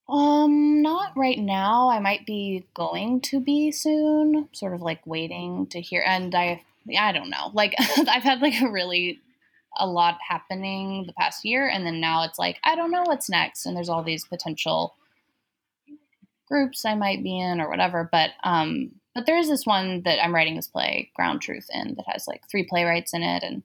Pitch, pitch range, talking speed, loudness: 200 Hz, 175-280 Hz, 200 wpm, -24 LUFS